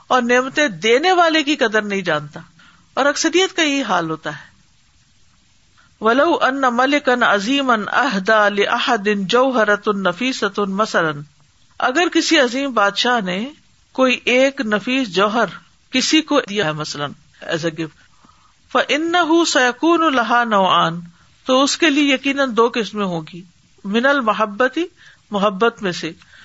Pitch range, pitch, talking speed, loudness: 200-275 Hz, 235 Hz, 105 wpm, -17 LUFS